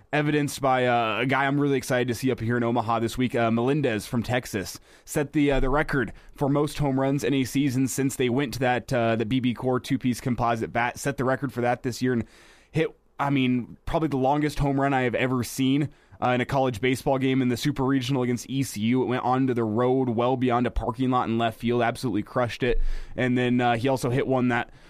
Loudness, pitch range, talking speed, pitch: -25 LUFS, 120-135 Hz, 240 wpm, 125 Hz